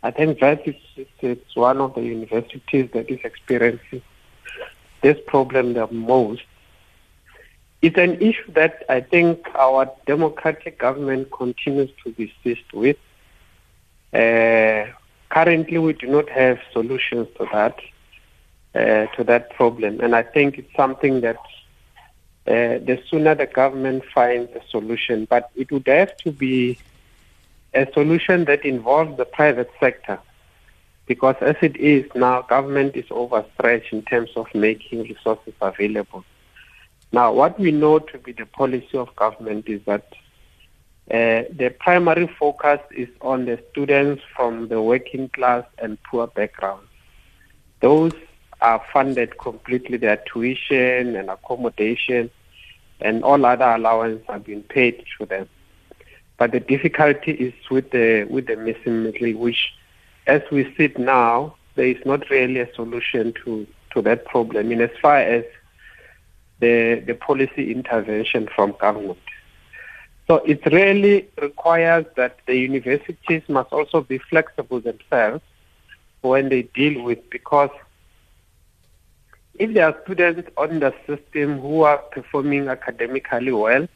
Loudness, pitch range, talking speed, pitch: -19 LUFS, 115-145 Hz, 140 wpm, 125 Hz